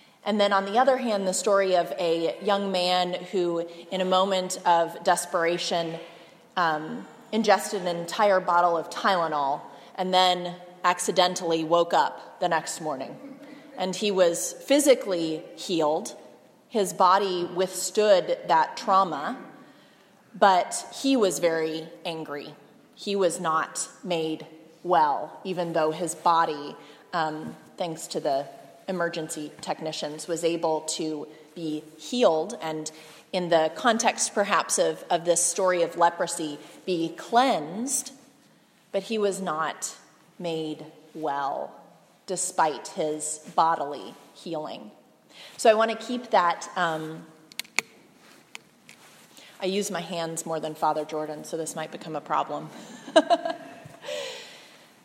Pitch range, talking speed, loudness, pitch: 160-195 Hz, 120 wpm, -26 LUFS, 175 Hz